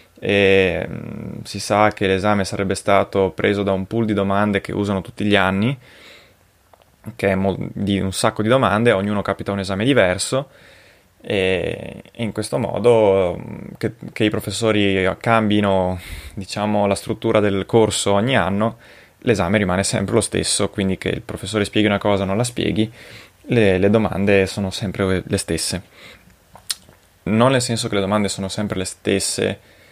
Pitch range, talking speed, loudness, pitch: 95-110 Hz, 165 wpm, -19 LUFS, 100 Hz